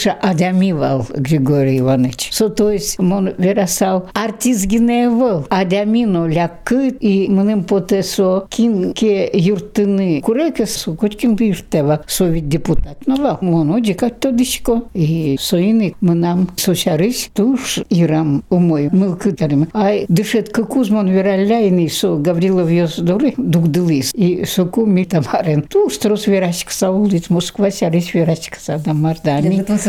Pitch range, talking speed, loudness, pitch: 170-210 Hz, 120 wpm, -15 LUFS, 190 Hz